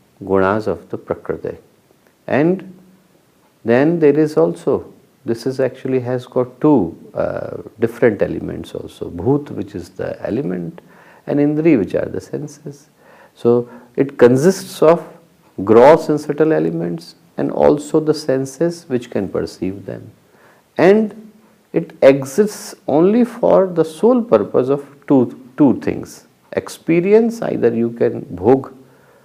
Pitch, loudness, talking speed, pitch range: 145 Hz, -16 LUFS, 130 wpm, 125-170 Hz